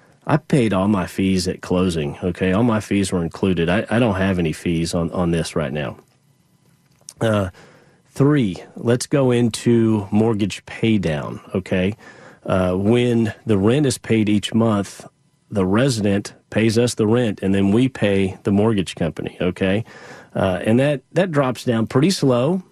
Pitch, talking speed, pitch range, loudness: 105 Hz, 165 wpm, 95-120 Hz, -19 LUFS